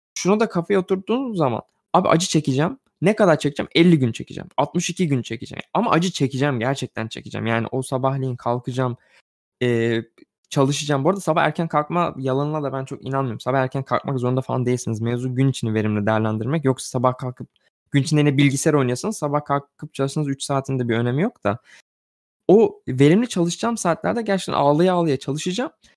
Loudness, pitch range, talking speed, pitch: -21 LUFS, 130-170 Hz, 170 wpm, 140 Hz